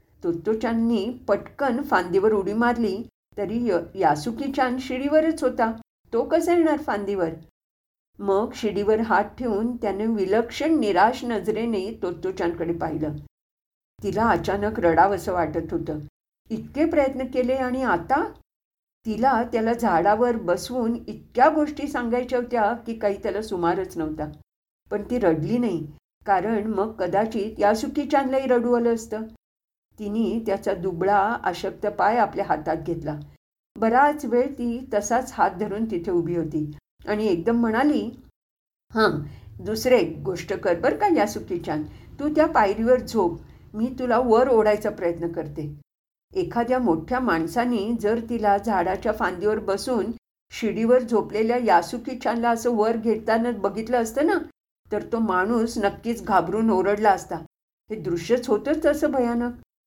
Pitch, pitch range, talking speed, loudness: 220 Hz, 195-245 Hz, 130 wpm, -23 LUFS